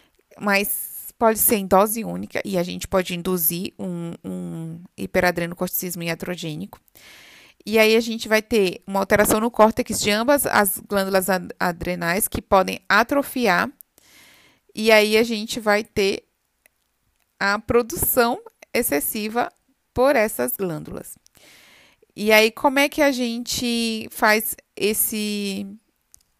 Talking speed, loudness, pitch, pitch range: 125 wpm, -21 LUFS, 210 Hz, 185-230 Hz